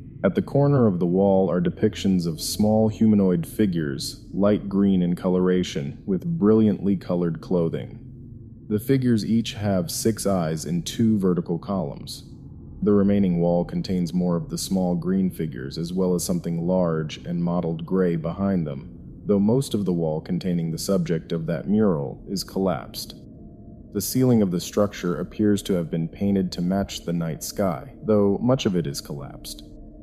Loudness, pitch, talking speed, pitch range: -23 LUFS, 95 Hz, 170 wpm, 85-105 Hz